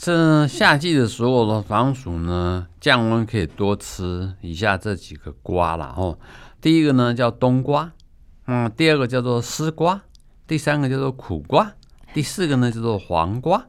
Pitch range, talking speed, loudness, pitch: 90-140 Hz, 235 characters per minute, -20 LUFS, 120 Hz